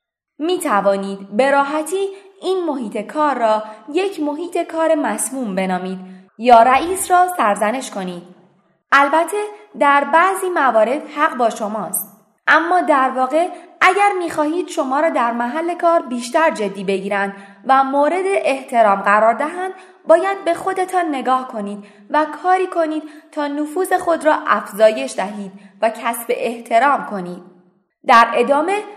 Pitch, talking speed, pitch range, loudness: 280 Hz, 135 wpm, 215-335 Hz, -17 LUFS